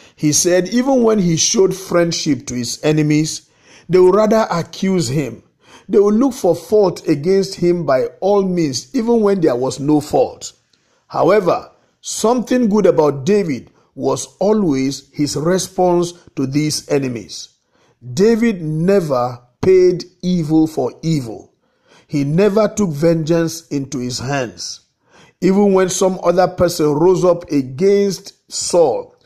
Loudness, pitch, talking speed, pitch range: -16 LUFS, 175 Hz, 135 wpm, 145-195 Hz